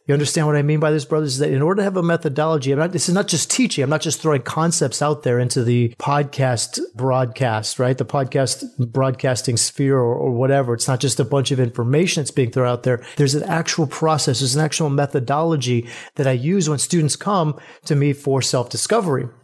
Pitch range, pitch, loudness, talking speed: 130-155 Hz, 140 Hz, -19 LUFS, 225 wpm